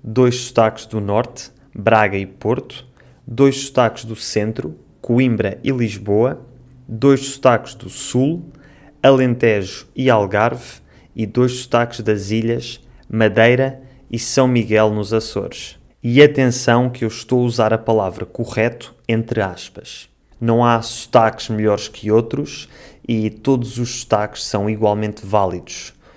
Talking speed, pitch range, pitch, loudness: 130 wpm, 110-125 Hz, 115 Hz, -17 LUFS